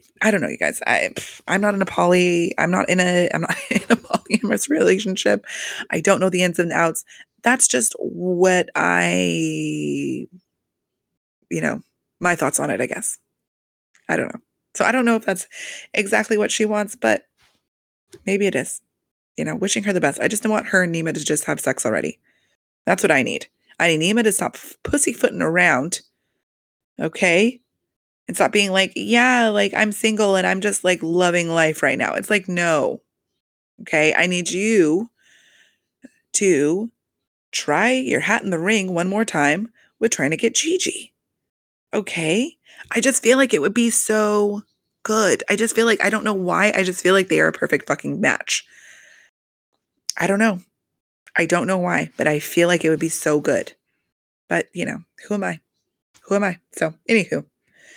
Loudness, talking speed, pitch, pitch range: -19 LUFS, 185 wpm, 195 Hz, 175-220 Hz